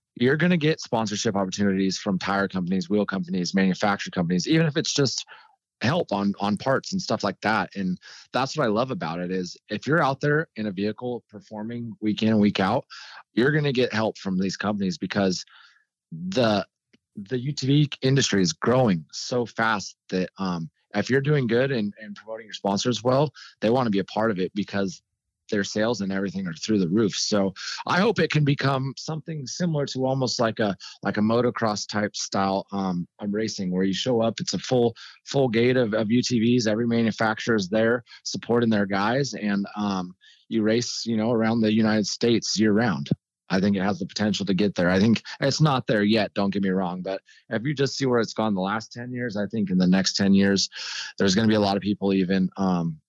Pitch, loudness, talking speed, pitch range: 110 Hz, -24 LUFS, 215 wpm, 100-125 Hz